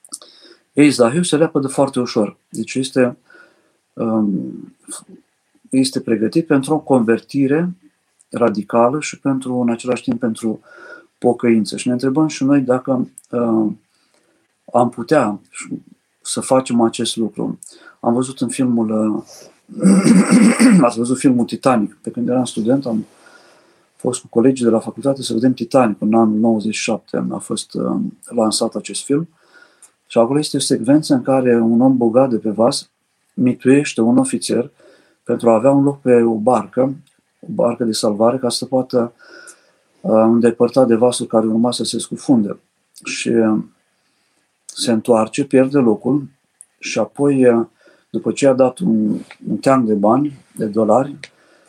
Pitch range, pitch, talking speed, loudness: 115-135 Hz, 125 Hz, 140 wpm, -16 LUFS